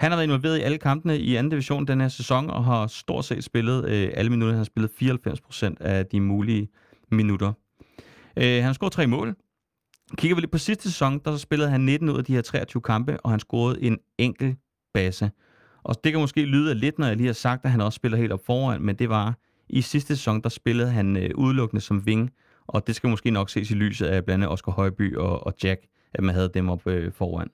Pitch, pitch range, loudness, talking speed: 120 Hz, 105-135 Hz, -24 LUFS, 240 wpm